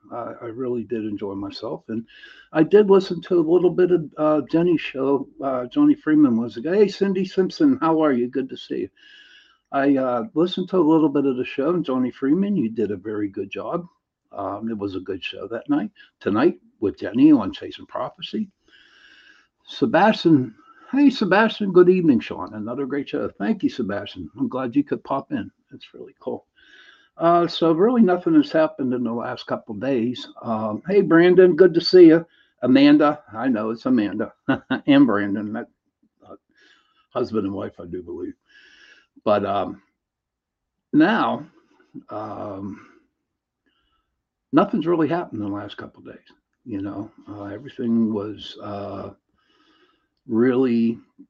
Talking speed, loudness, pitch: 165 wpm, -20 LUFS, 165 Hz